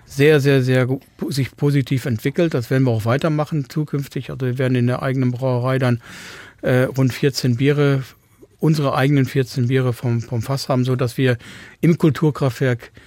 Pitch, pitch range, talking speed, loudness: 130 Hz, 125-140 Hz, 165 wpm, -19 LUFS